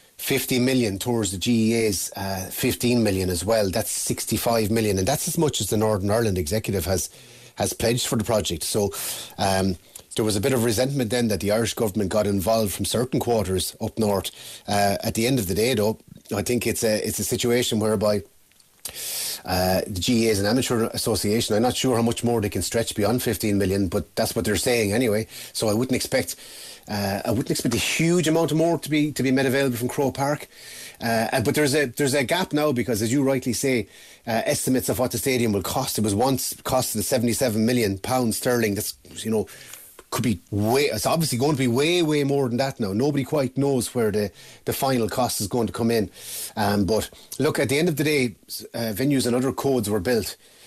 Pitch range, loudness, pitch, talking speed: 105-130 Hz, -23 LUFS, 115 Hz, 220 wpm